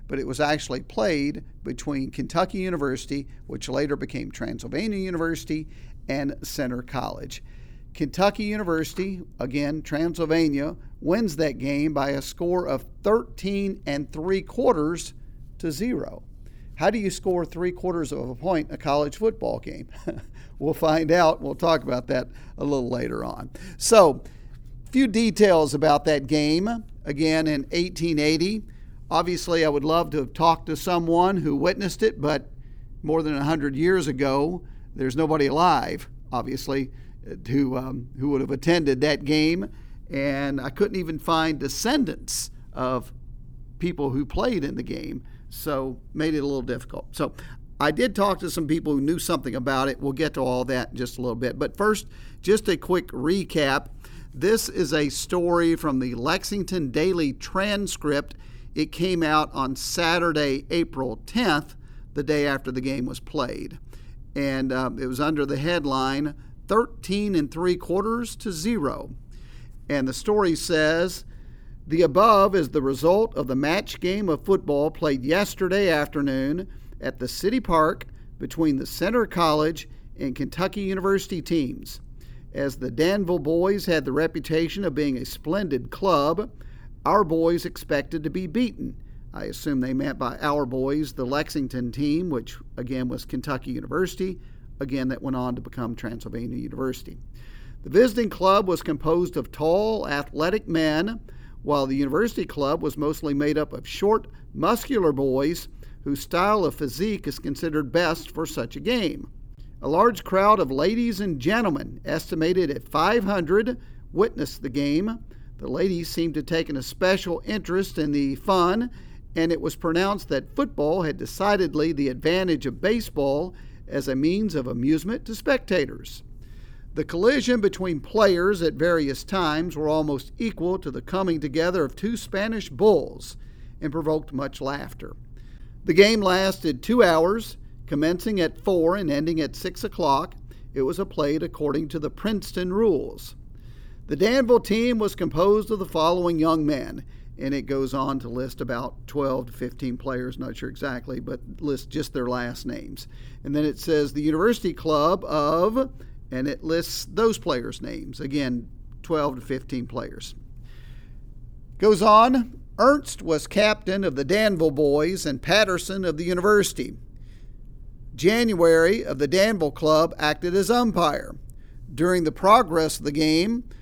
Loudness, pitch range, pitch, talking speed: -24 LUFS, 135-185 Hz, 155 Hz, 155 wpm